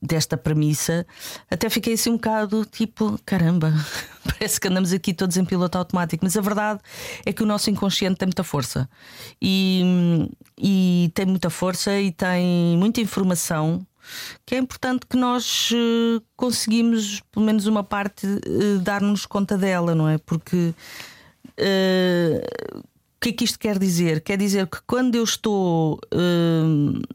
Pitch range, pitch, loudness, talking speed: 175-215 Hz, 195 Hz, -22 LUFS, 145 wpm